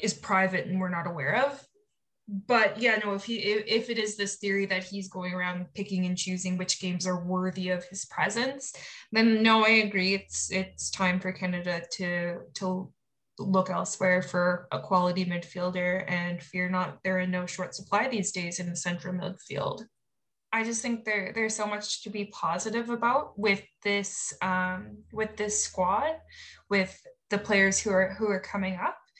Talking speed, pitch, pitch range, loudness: 180 wpm, 190 Hz, 180-210 Hz, -28 LUFS